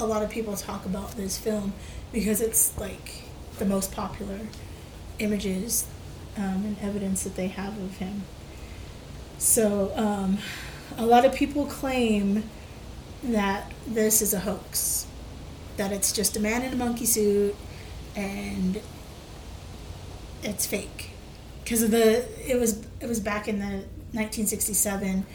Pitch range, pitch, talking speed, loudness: 195-220 Hz, 205 Hz, 135 wpm, -26 LUFS